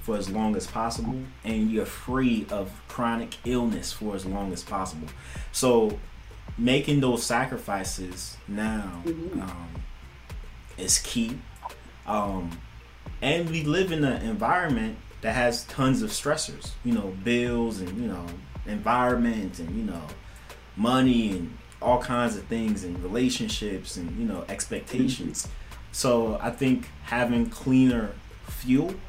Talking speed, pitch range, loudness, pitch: 130 wpm, 95-125 Hz, -27 LUFS, 115 Hz